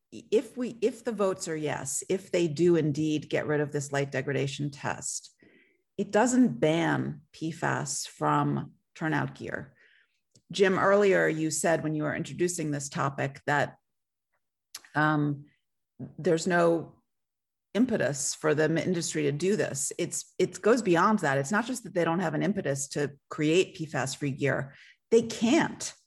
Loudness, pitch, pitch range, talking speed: -28 LUFS, 160 Hz, 145-190 Hz, 155 wpm